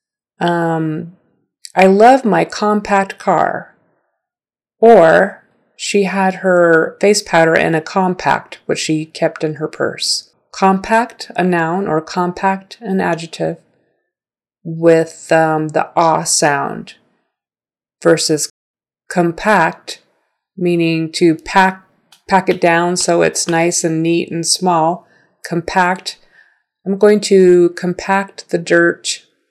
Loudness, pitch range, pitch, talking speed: -14 LUFS, 165-195 Hz, 175 Hz, 110 wpm